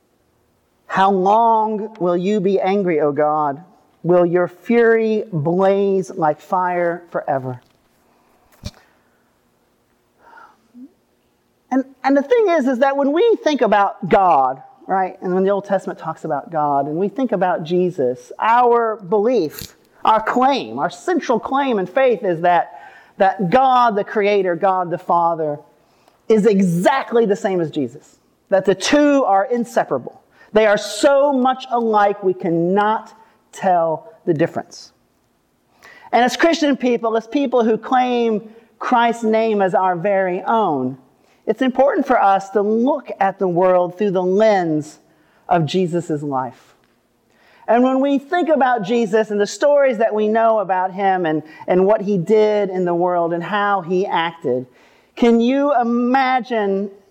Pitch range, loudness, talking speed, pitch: 180-240 Hz, -17 LUFS, 145 wpm, 205 Hz